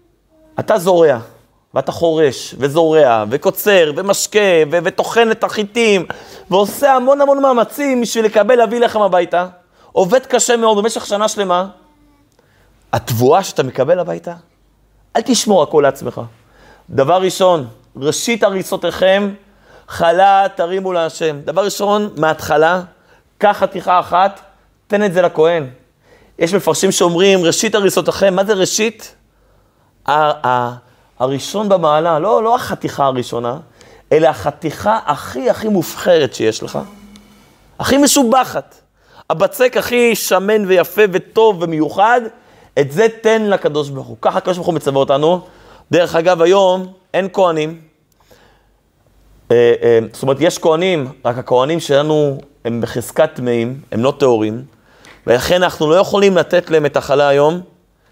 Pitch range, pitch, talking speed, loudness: 150-210 Hz, 180 Hz, 125 wpm, -14 LUFS